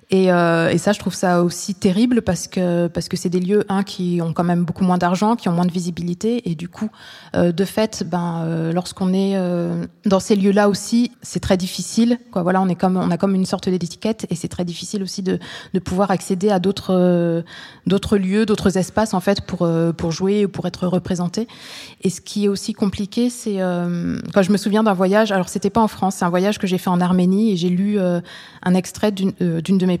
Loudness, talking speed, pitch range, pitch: -19 LUFS, 245 wpm, 180-205 Hz, 190 Hz